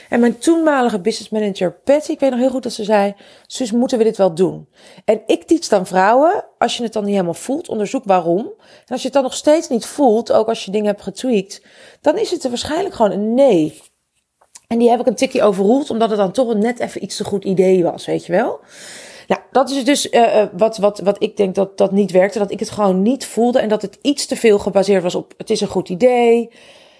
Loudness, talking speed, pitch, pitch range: -16 LUFS, 250 wpm, 220 Hz, 195-255 Hz